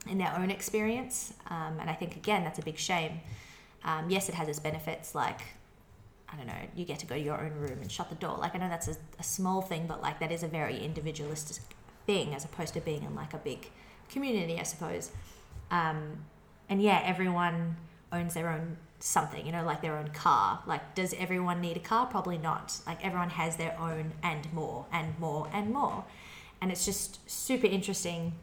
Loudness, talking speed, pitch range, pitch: -34 LUFS, 210 wpm, 155-185 Hz, 165 Hz